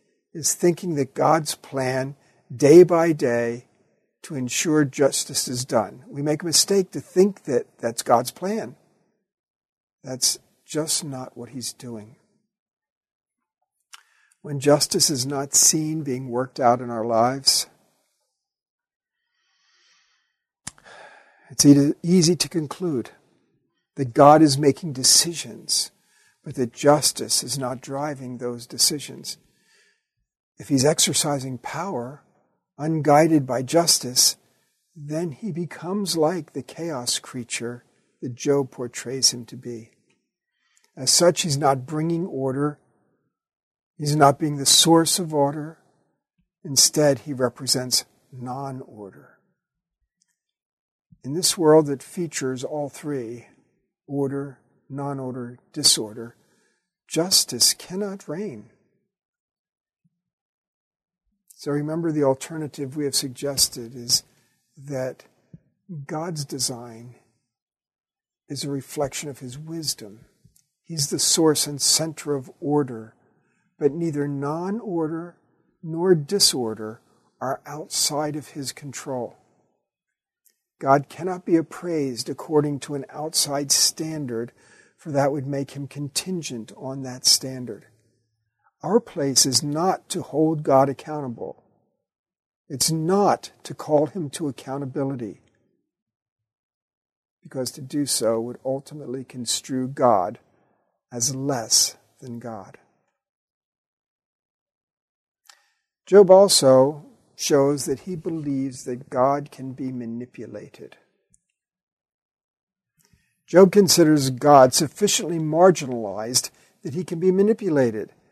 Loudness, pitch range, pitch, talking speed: -21 LUFS, 130-160 Hz, 145 Hz, 105 wpm